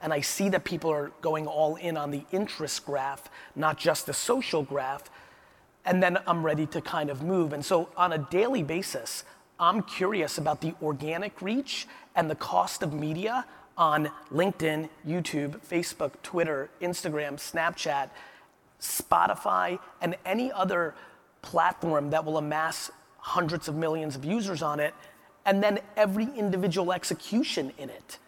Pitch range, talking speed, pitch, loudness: 150-190 Hz, 155 wpm, 165 Hz, -29 LUFS